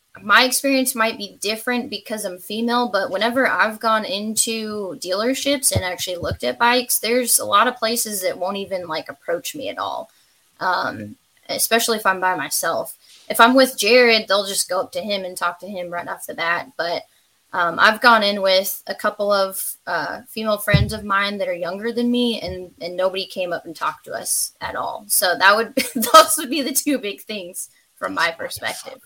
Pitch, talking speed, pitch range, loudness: 215 Hz, 205 wpm, 190-245 Hz, -19 LUFS